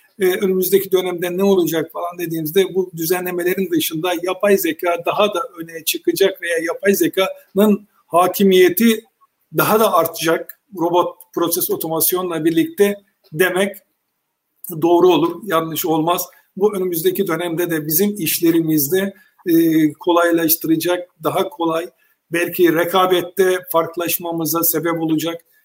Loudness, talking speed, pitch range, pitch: -17 LUFS, 110 wpm, 165-195 Hz, 180 Hz